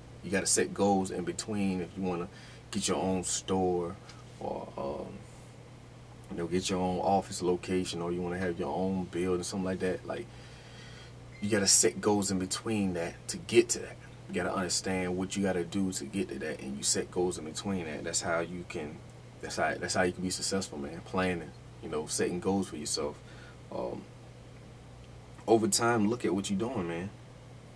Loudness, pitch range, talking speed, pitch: -31 LUFS, 90-110 Hz, 195 wpm, 95 Hz